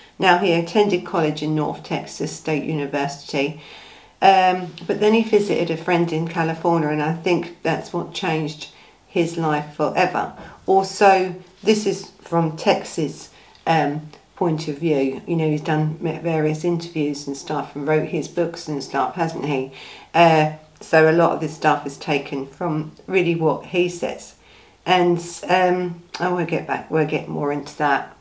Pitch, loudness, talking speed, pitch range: 165 Hz, -21 LUFS, 160 wpm, 150-175 Hz